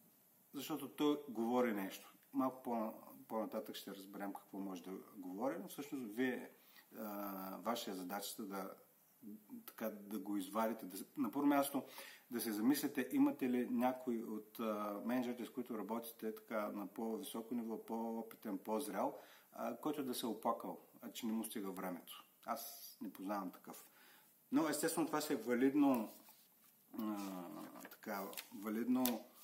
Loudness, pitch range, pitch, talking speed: -42 LUFS, 105-135 Hz, 115 Hz, 140 wpm